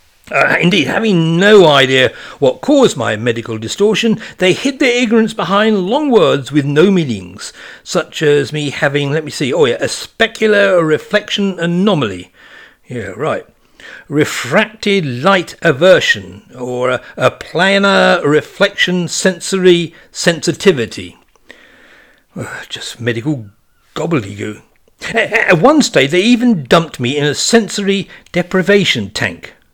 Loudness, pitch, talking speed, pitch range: -13 LUFS, 175 Hz, 125 wpm, 140-205 Hz